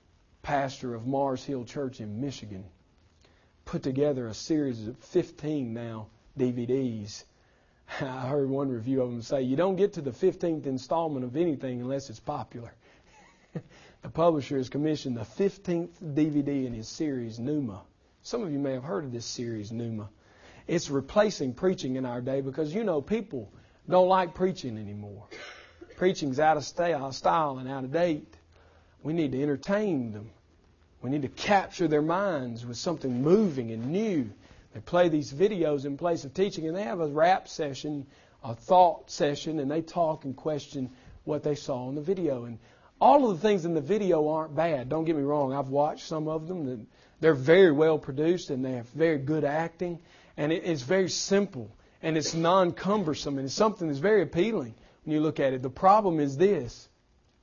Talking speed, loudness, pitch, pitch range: 180 wpm, -28 LUFS, 145 Hz, 125-165 Hz